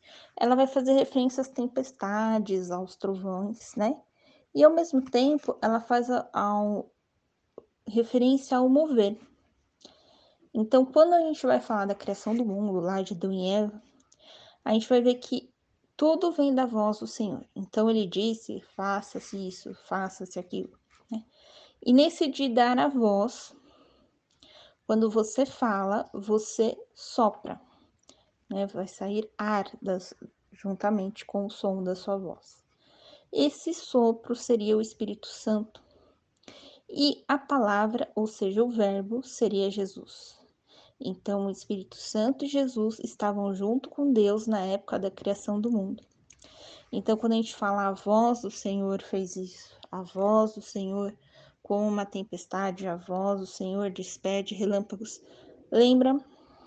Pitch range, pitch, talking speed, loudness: 200-255 Hz, 215 Hz, 140 wpm, -28 LUFS